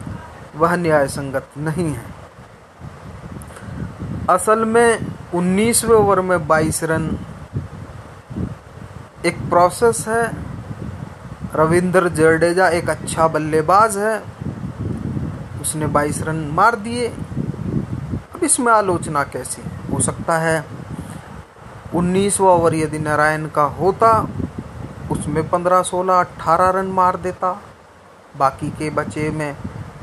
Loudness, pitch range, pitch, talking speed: -18 LUFS, 150-185 Hz, 160 Hz, 100 wpm